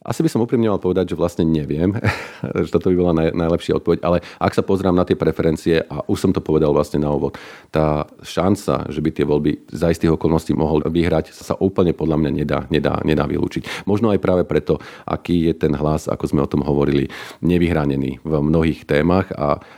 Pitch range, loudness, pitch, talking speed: 75-90 Hz, -19 LUFS, 80 Hz, 205 wpm